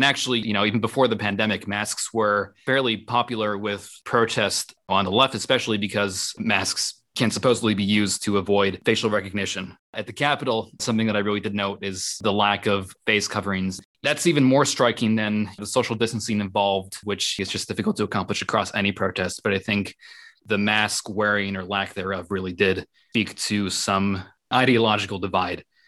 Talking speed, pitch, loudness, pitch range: 180 wpm, 105 Hz, -23 LUFS, 100-110 Hz